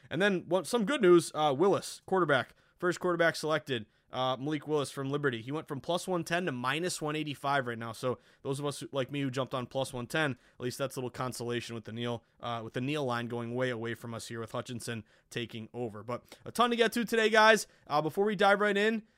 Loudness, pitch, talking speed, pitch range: -31 LUFS, 140 Hz, 240 wpm, 120-170 Hz